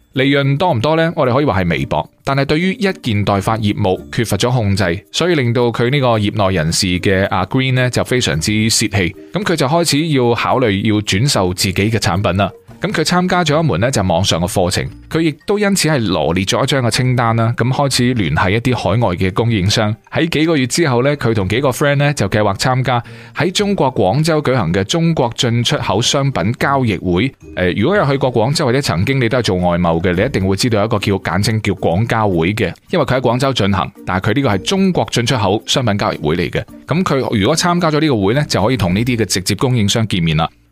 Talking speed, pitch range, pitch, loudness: 360 characters per minute, 100-140 Hz, 115 Hz, -15 LUFS